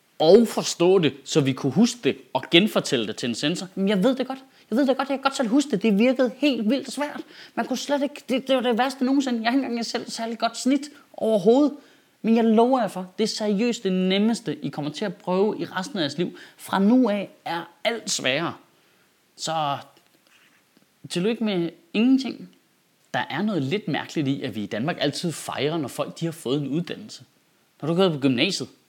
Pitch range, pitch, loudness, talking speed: 170-255 Hz, 220 Hz, -23 LUFS, 220 wpm